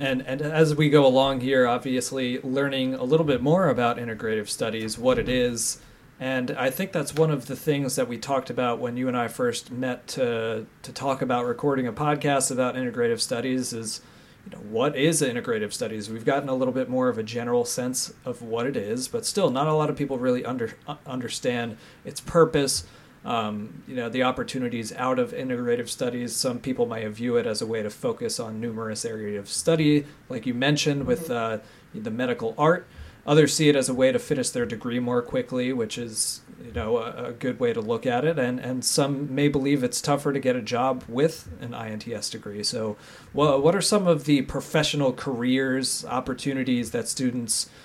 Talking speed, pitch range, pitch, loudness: 205 wpm, 120-150 Hz, 130 Hz, -25 LUFS